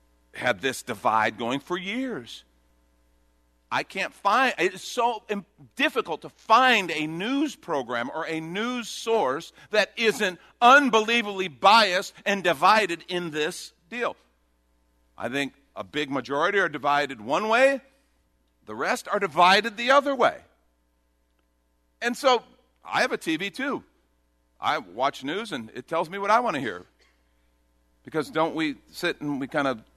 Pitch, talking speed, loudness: 160 Hz, 145 wpm, -24 LUFS